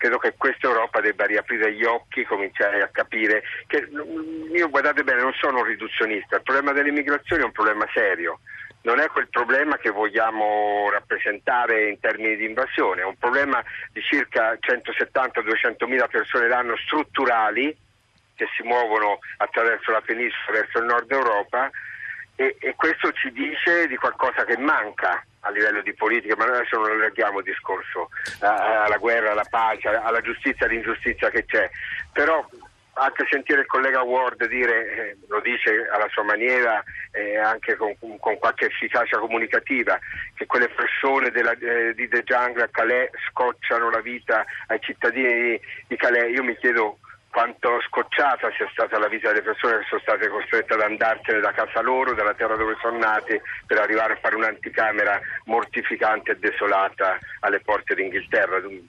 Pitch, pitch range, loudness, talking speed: 120 Hz, 110-130 Hz, -22 LUFS, 165 wpm